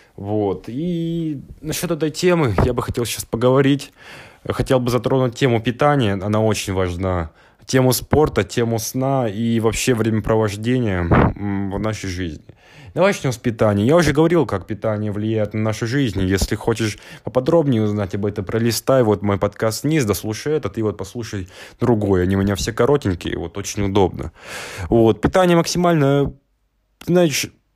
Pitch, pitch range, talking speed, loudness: 115 Hz, 105-135 Hz, 150 wpm, -19 LUFS